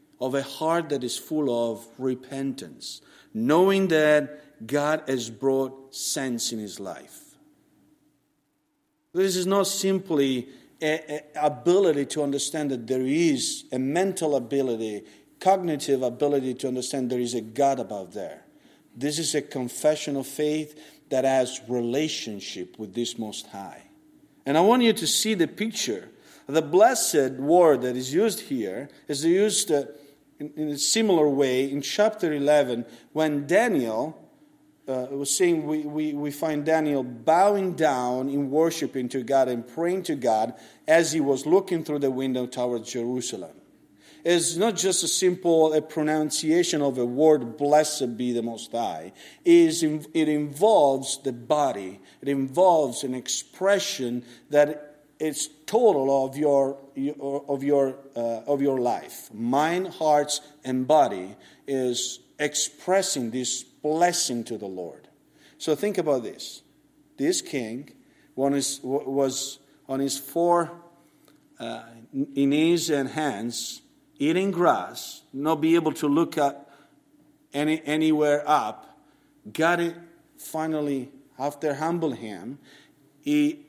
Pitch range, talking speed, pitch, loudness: 130-165 Hz, 135 wpm, 145 Hz, -24 LUFS